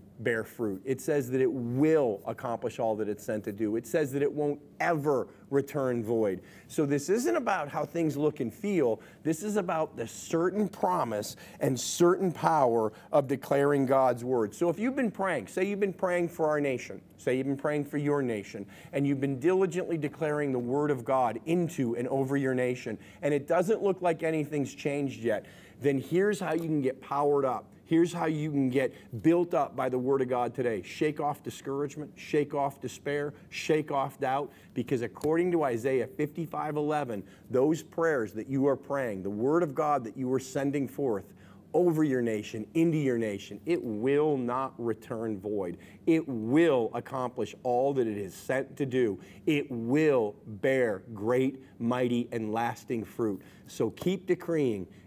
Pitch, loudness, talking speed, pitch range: 140 Hz, -30 LUFS, 180 wpm, 120-155 Hz